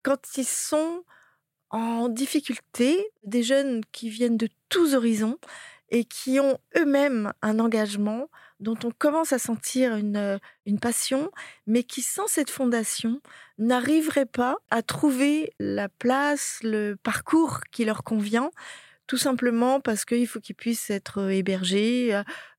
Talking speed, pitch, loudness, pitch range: 135 wpm, 240 Hz, -25 LUFS, 220-275 Hz